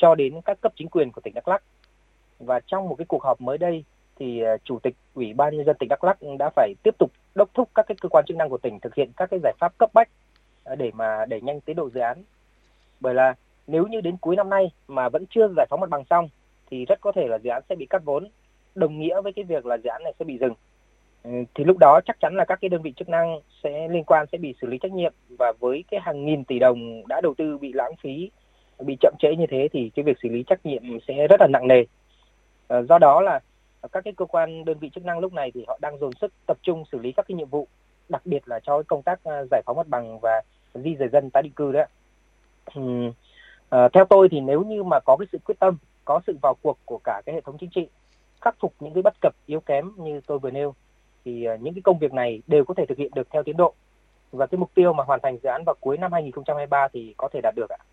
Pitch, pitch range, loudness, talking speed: 155 Hz, 135-185 Hz, -22 LUFS, 270 wpm